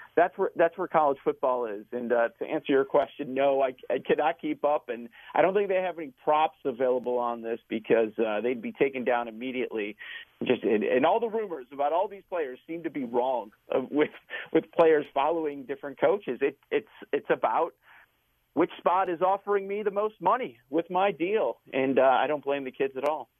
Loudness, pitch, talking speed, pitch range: -28 LUFS, 150 Hz, 210 wpm, 130-190 Hz